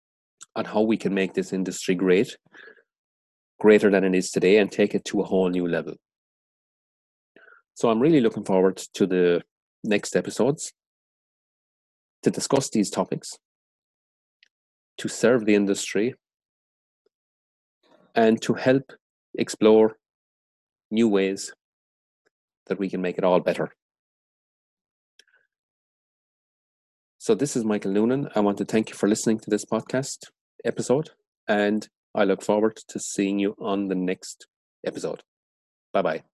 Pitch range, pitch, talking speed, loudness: 85-110 Hz, 100 Hz, 130 wpm, -24 LUFS